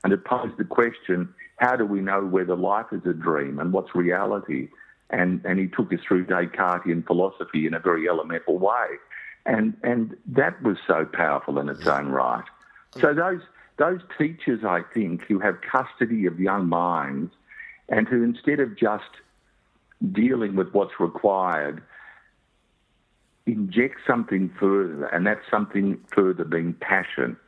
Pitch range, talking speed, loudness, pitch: 90-115 Hz, 155 wpm, -24 LUFS, 95 Hz